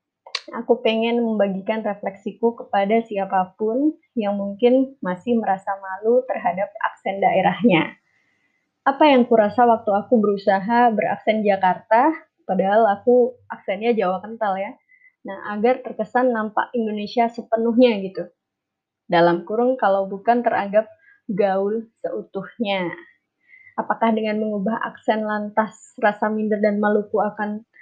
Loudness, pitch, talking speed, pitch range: -21 LUFS, 220 Hz, 110 wpm, 200-240 Hz